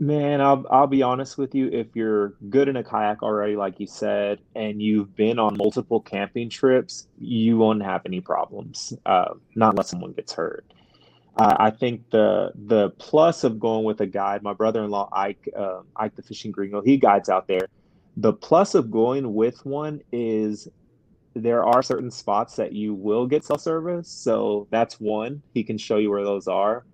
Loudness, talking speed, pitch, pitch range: -23 LUFS, 190 wpm, 110 Hz, 105-130 Hz